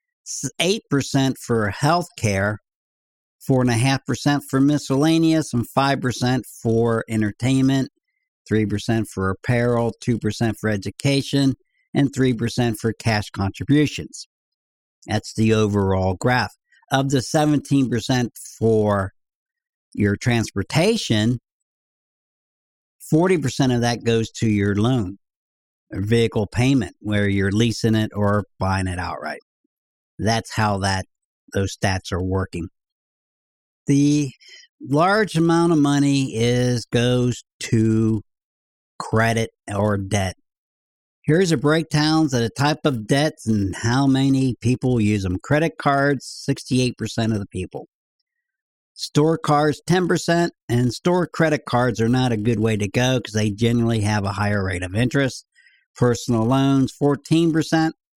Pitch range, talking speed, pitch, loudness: 105-145 Hz, 115 wpm, 120 Hz, -21 LUFS